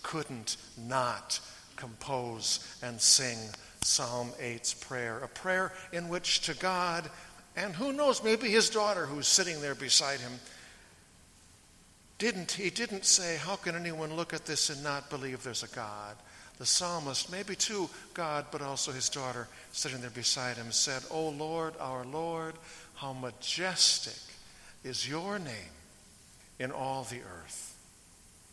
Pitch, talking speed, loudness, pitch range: 140 Hz, 145 wpm, -31 LUFS, 120-170 Hz